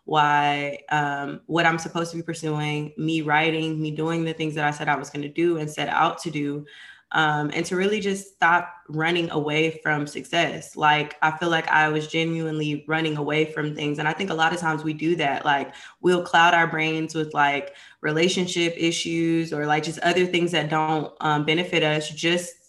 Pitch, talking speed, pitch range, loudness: 155 Hz, 205 wpm, 150-165 Hz, -23 LUFS